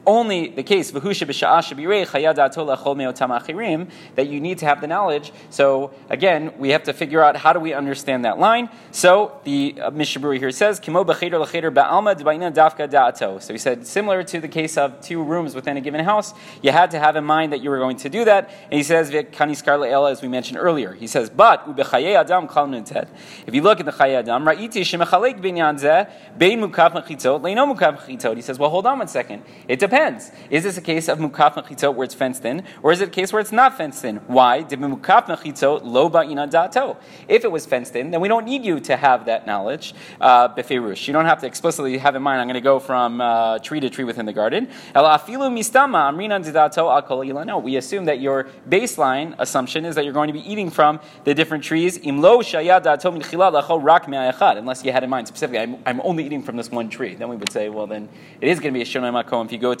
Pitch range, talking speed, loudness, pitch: 135-180 Hz, 190 wpm, -19 LUFS, 155 Hz